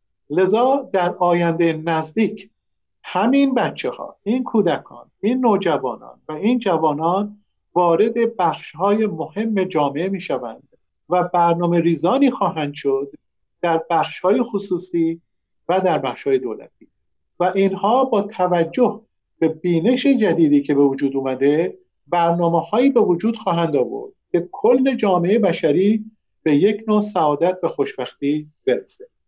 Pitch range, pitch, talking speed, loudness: 165-220 Hz, 180 Hz, 130 wpm, -19 LUFS